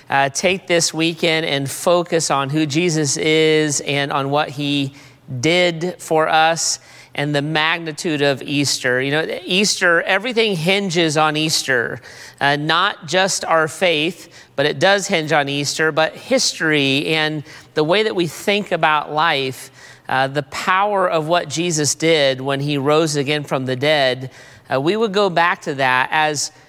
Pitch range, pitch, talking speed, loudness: 145-170 Hz, 155 Hz, 160 wpm, -17 LUFS